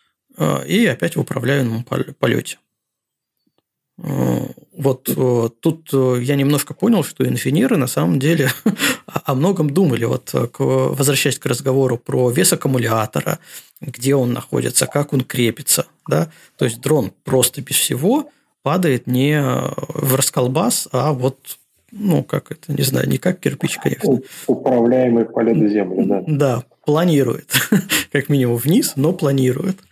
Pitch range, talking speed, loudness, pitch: 125-155 Hz, 130 wpm, -18 LUFS, 140 Hz